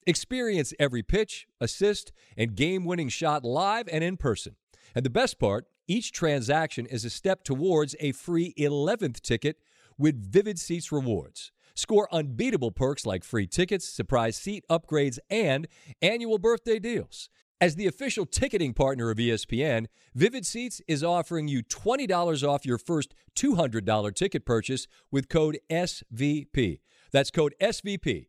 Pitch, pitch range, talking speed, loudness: 150 Hz, 125-185 Hz, 145 wpm, -28 LUFS